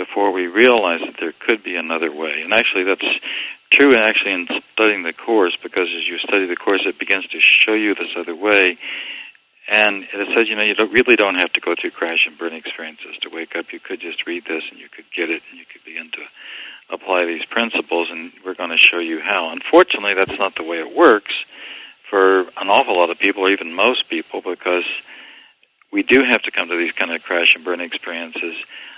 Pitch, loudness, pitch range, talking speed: 100 Hz, -17 LUFS, 85-125 Hz, 220 wpm